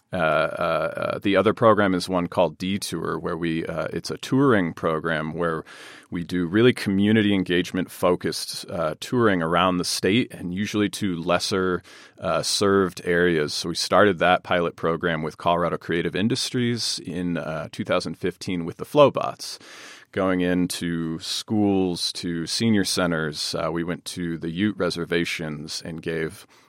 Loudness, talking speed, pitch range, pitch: -23 LUFS, 150 wpm, 85-100 Hz, 90 Hz